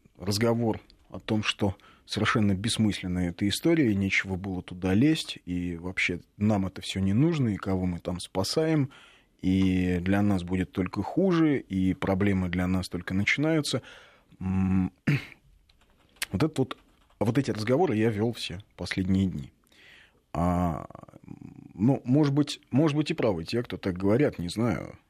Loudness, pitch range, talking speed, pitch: -27 LUFS, 90-120 Hz, 150 wpm, 100 Hz